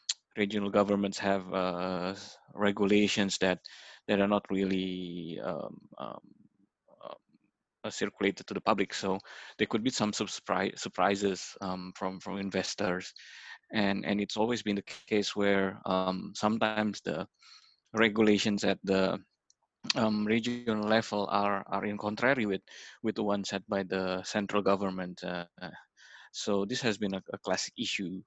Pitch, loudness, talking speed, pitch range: 100 Hz, -31 LUFS, 140 wpm, 95-105 Hz